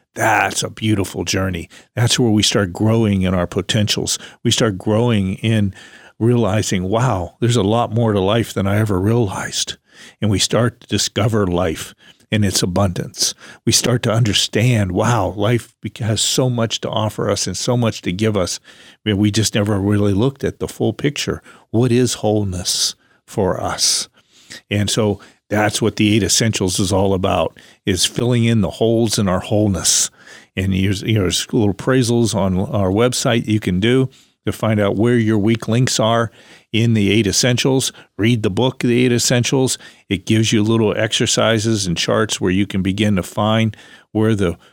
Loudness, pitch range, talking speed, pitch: -17 LUFS, 100-115 Hz, 175 wpm, 110 Hz